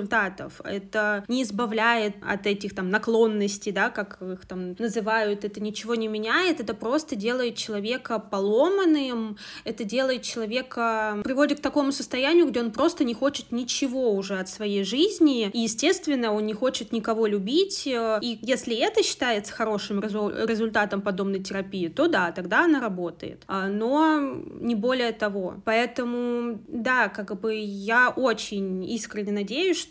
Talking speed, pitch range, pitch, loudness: 145 wpm, 210-255 Hz, 225 Hz, -25 LUFS